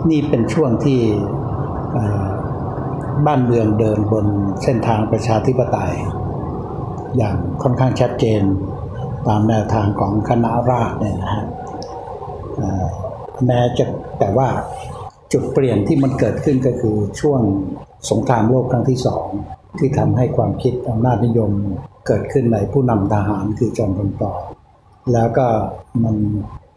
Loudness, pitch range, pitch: -18 LUFS, 105-125 Hz, 115 Hz